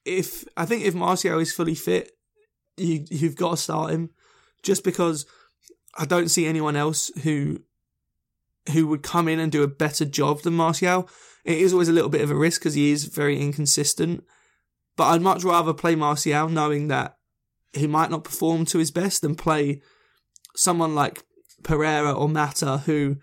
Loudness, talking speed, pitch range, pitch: -23 LUFS, 180 wpm, 150-175 Hz, 160 Hz